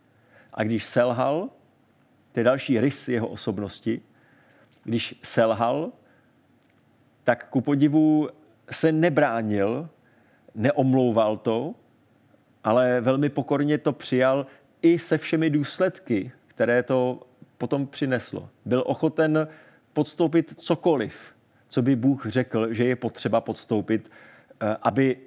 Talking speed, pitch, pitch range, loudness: 105 wpm, 130 Hz, 115-145 Hz, -24 LUFS